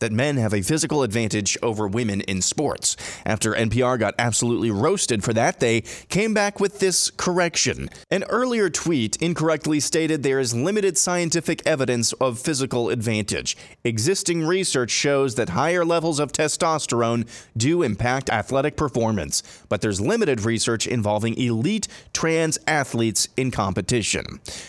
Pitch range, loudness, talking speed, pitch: 115-165 Hz, -22 LUFS, 140 wpm, 125 Hz